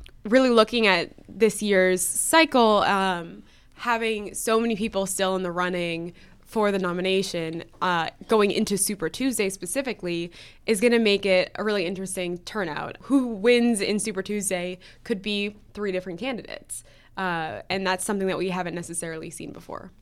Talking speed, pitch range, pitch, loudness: 160 wpm, 180-220 Hz, 195 Hz, -24 LUFS